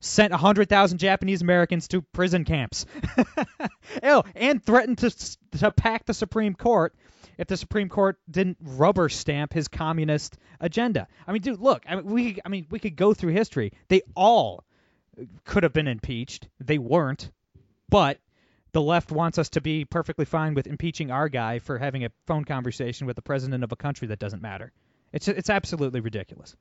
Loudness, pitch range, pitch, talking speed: -25 LUFS, 140-200 Hz, 165 Hz, 180 wpm